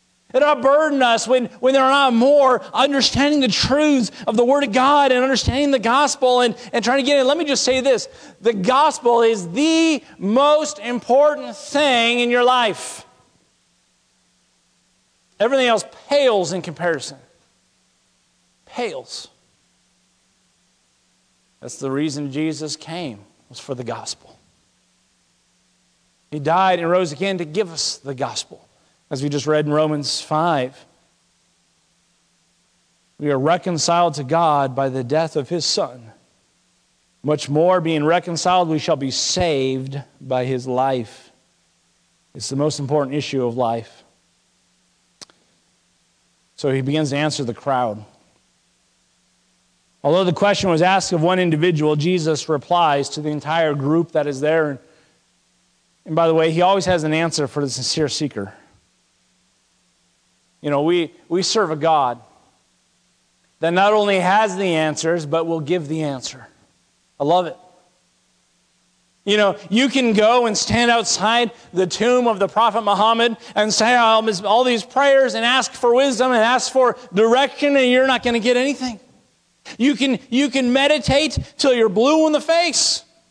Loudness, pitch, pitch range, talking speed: -18 LUFS, 185 Hz, 155-250 Hz, 150 wpm